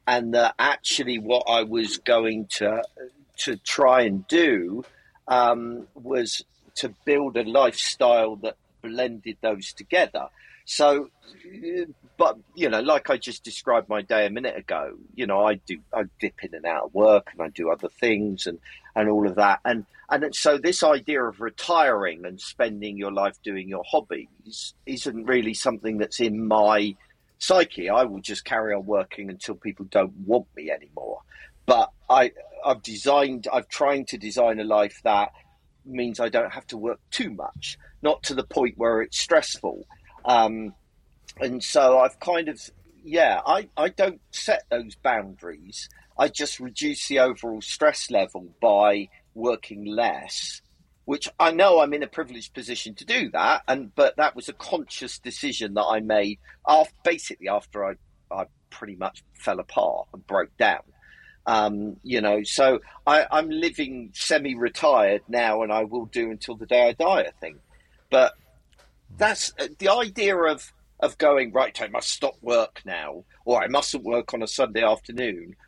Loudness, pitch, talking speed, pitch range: -23 LUFS, 115 Hz, 170 wpm, 105-130 Hz